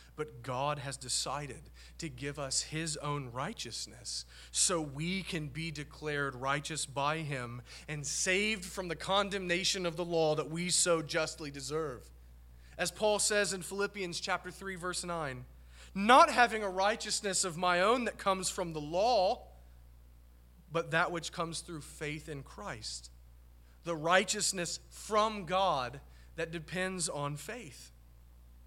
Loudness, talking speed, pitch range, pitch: -33 LUFS, 140 wpm, 135-185 Hz, 160 Hz